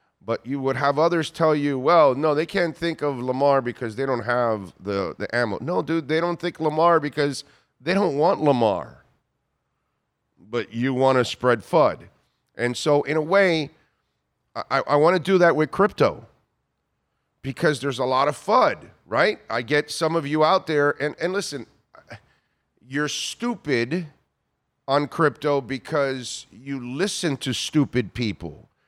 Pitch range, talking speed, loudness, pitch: 125-160 Hz, 160 wpm, -22 LUFS, 145 Hz